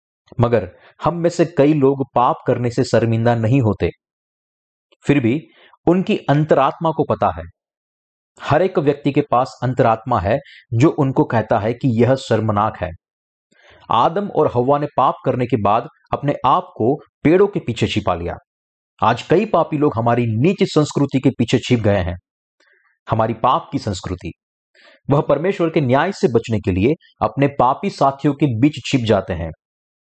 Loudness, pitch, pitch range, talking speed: -18 LUFS, 125 Hz, 105-150 Hz, 165 wpm